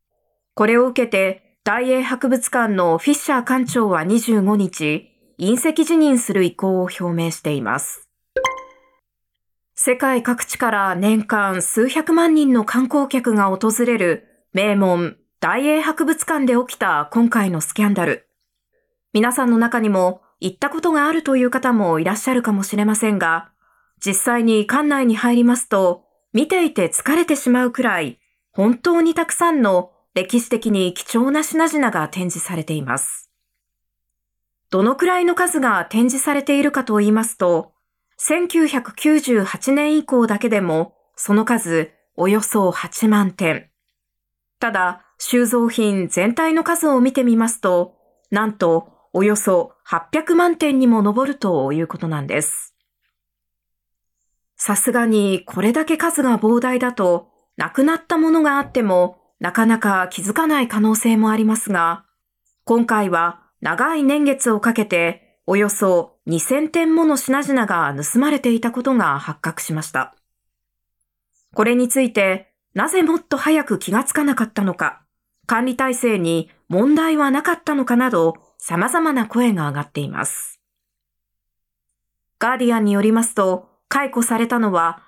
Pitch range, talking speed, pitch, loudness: 190-270 Hz, 275 characters per minute, 230 Hz, -18 LUFS